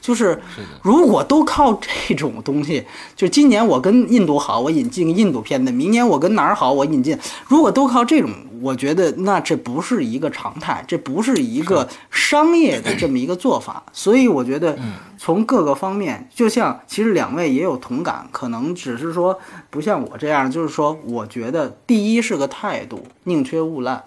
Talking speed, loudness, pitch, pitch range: 280 characters per minute, -18 LUFS, 220 Hz, 160-260 Hz